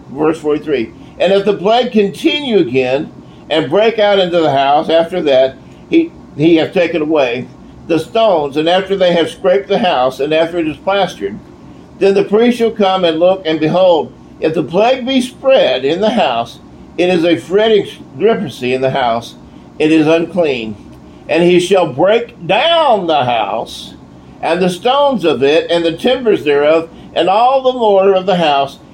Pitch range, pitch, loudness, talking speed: 155-210 Hz, 175 Hz, -13 LUFS, 180 wpm